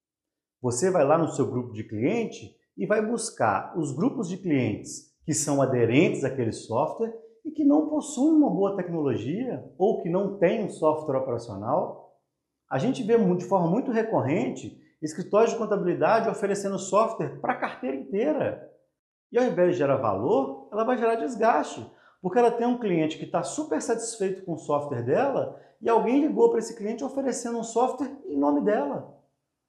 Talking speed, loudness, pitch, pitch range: 170 wpm, -26 LUFS, 195 Hz, 155-230 Hz